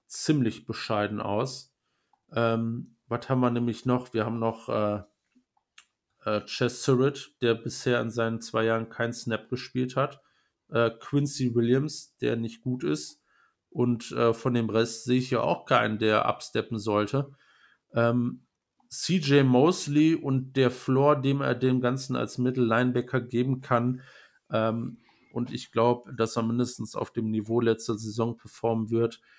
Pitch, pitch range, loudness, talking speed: 120 Hz, 115-130 Hz, -27 LUFS, 150 wpm